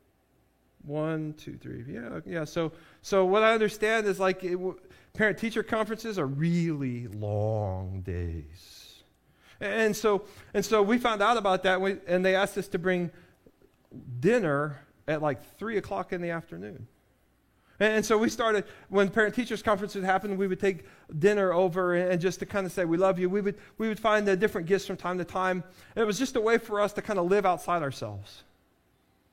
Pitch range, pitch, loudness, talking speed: 165-210 Hz, 190 Hz, -28 LUFS, 195 wpm